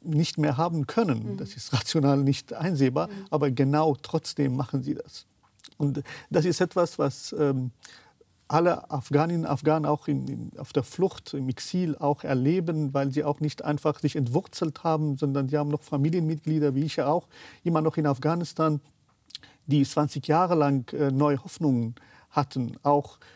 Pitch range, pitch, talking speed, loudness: 140-160 Hz, 145 Hz, 165 wpm, -27 LUFS